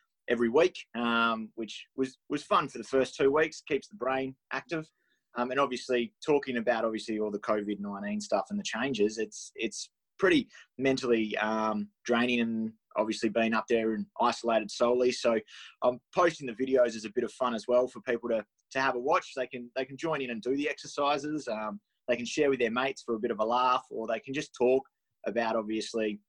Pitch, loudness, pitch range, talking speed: 120 Hz, -30 LUFS, 110-130 Hz, 215 wpm